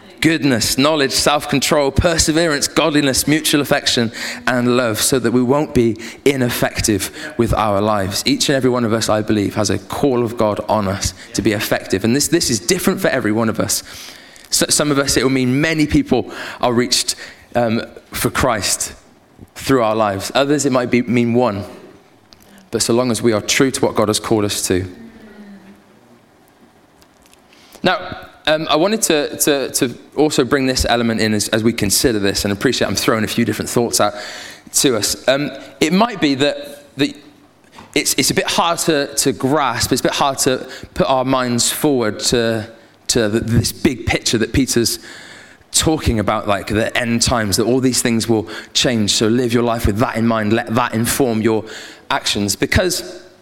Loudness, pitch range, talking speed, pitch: -16 LUFS, 110-140 Hz, 190 wpm, 120 Hz